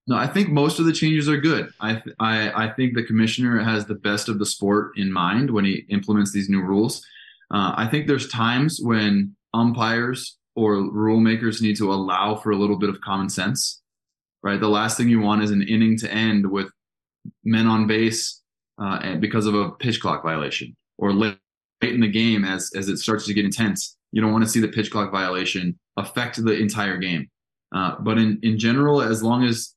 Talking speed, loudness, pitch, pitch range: 210 wpm, -21 LUFS, 110 Hz, 100-115 Hz